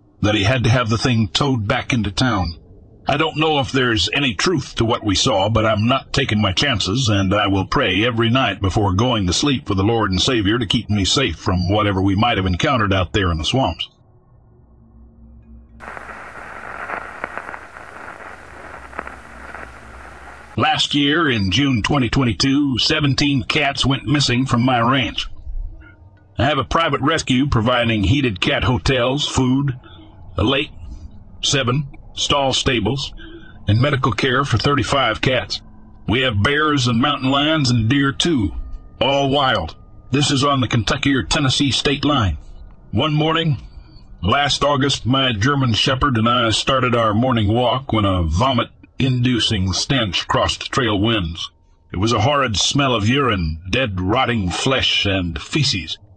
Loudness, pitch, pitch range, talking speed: -17 LUFS, 120 Hz, 100-135 Hz, 155 wpm